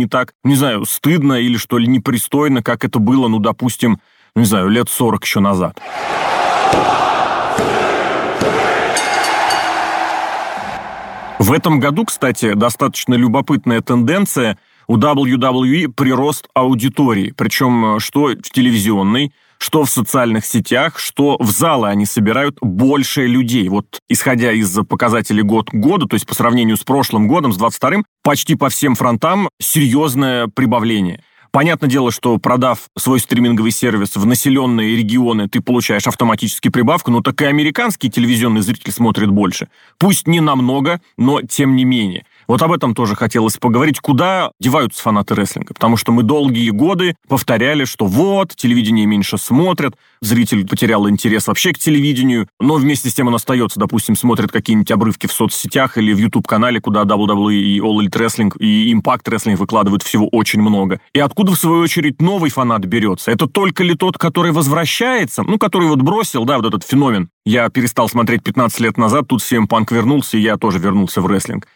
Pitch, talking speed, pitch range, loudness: 125 Hz, 160 wpm, 110-150 Hz, -14 LUFS